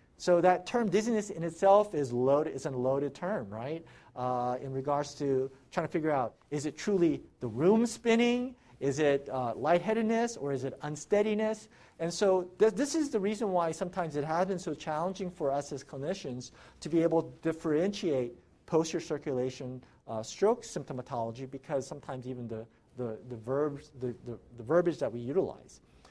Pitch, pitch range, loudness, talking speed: 150 Hz, 130-185 Hz, -31 LUFS, 175 wpm